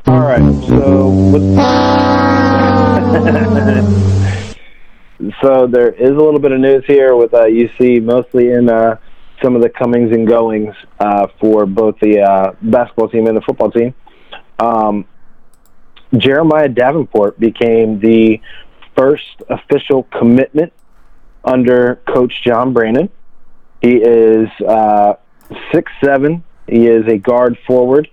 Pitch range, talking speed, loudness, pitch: 110-130 Hz, 125 wpm, -11 LUFS, 115 Hz